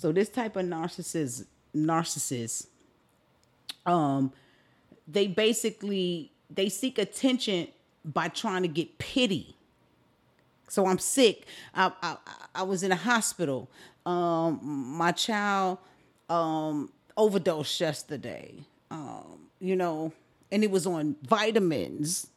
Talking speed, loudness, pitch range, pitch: 110 wpm, -29 LUFS, 155-205 Hz, 180 Hz